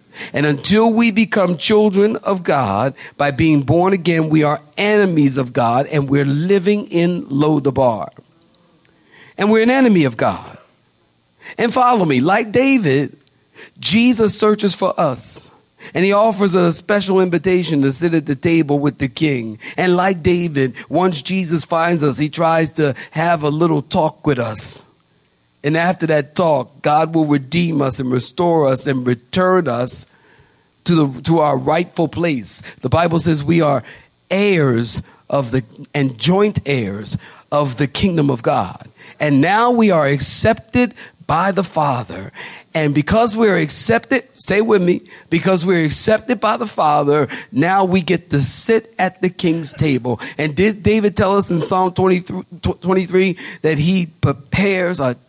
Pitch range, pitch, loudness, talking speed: 145-190 Hz, 165 Hz, -16 LUFS, 160 wpm